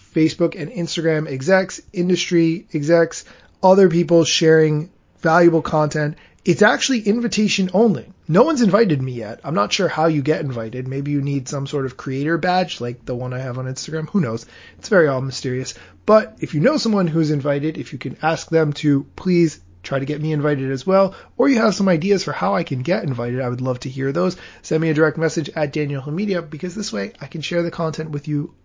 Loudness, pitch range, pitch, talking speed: -19 LUFS, 140-180 Hz, 160 Hz, 215 wpm